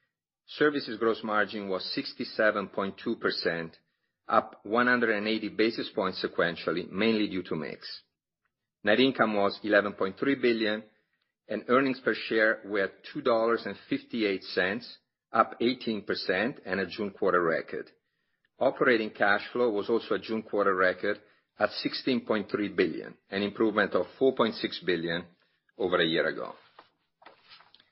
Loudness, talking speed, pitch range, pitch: -28 LUFS, 115 wpm, 100-115 Hz, 110 Hz